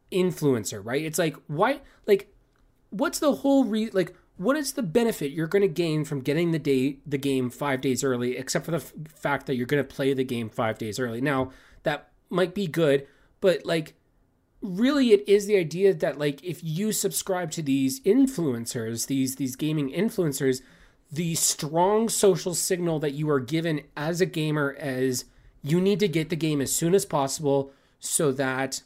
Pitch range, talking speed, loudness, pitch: 135-185 Hz, 185 wpm, -26 LUFS, 155 Hz